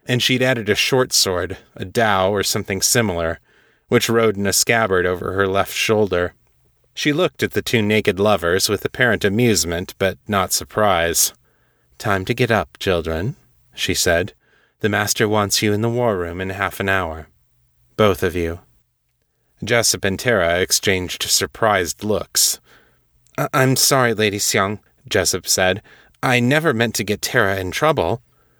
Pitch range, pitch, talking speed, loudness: 95-115 Hz, 105 Hz, 155 wpm, -18 LUFS